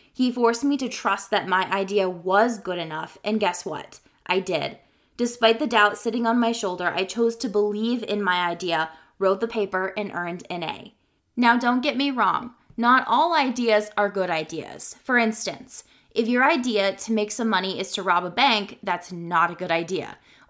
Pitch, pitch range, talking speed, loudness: 210 Hz, 185-235 Hz, 195 wpm, -23 LUFS